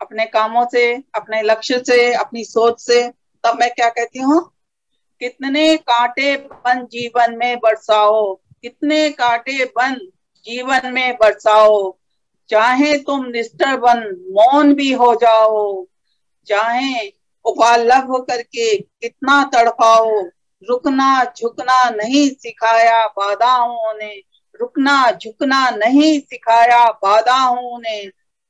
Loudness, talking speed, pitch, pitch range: -15 LUFS, 105 wpm, 240 Hz, 225-270 Hz